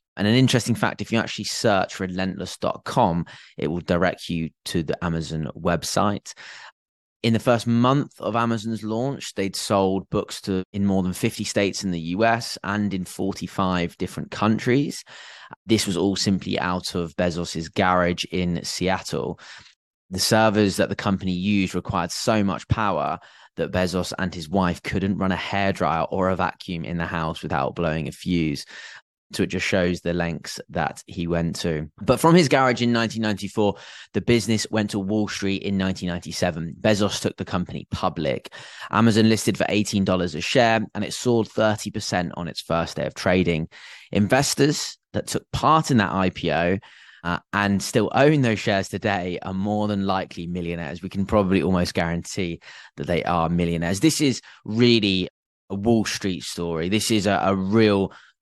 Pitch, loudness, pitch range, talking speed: 95 Hz, -23 LUFS, 90-110 Hz, 170 wpm